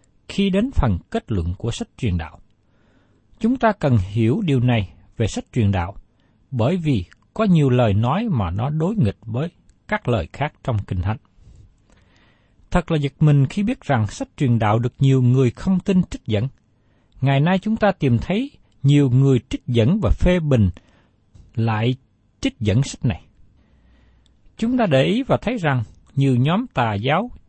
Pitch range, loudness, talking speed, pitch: 105-155 Hz, -20 LUFS, 180 wpm, 120 Hz